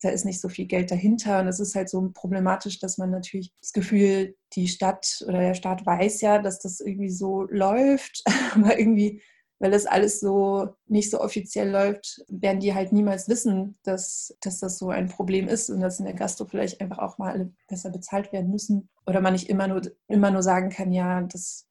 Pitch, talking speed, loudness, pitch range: 195 Hz, 215 wpm, -25 LUFS, 185-205 Hz